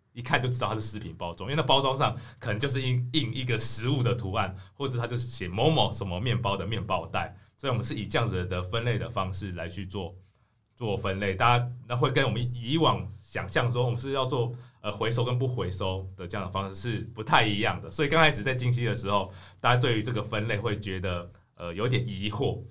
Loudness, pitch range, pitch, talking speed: -28 LUFS, 100-125 Hz, 115 Hz, 345 characters per minute